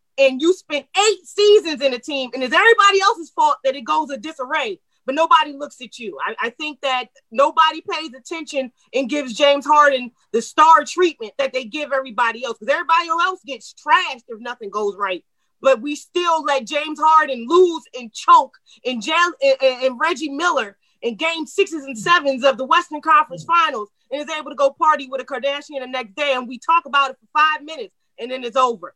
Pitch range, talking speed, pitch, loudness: 260-320 Hz, 210 wpm, 285 Hz, -18 LUFS